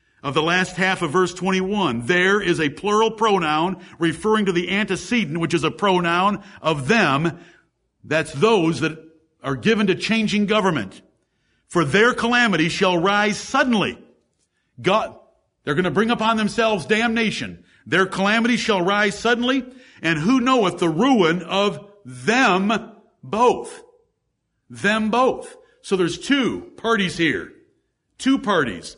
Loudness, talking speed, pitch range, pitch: -20 LUFS, 135 wpm, 170-225 Hz, 200 Hz